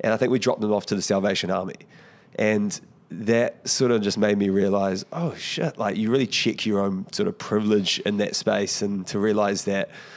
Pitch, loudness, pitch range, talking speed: 105 Hz, -23 LUFS, 100-115 Hz, 220 wpm